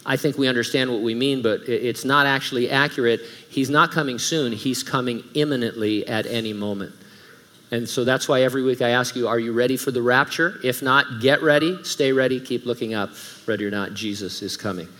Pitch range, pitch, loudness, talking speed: 115-135 Hz, 125 Hz, -21 LUFS, 210 wpm